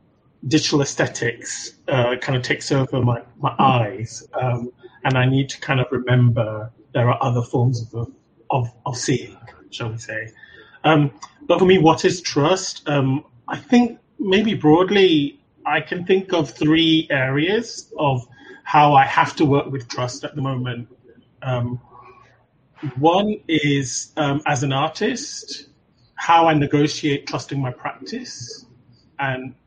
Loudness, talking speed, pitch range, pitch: -20 LUFS, 145 wpm, 125-160 Hz, 140 Hz